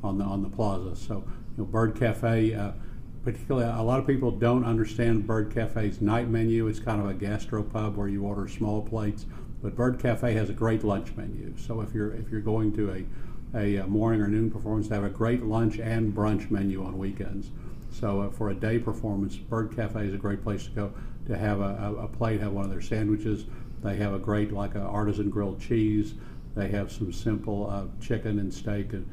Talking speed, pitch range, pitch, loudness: 215 wpm, 100-115 Hz, 105 Hz, -29 LUFS